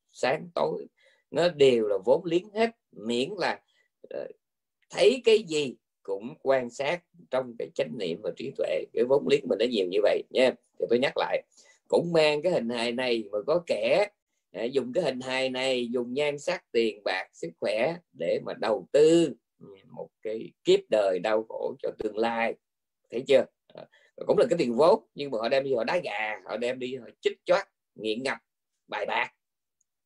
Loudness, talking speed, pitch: -27 LUFS, 195 wpm, 210 Hz